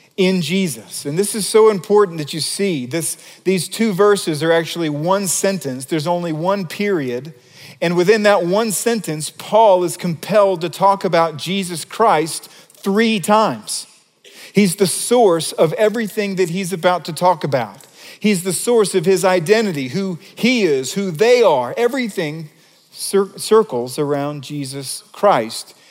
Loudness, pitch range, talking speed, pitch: -17 LUFS, 160-205 Hz, 155 wpm, 185 Hz